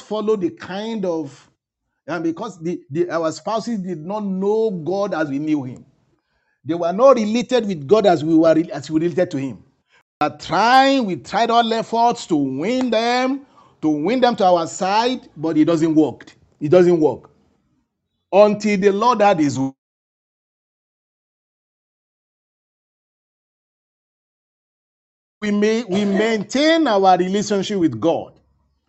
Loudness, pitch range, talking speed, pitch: -18 LUFS, 160-225 Hz, 140 wpm, 195 Hz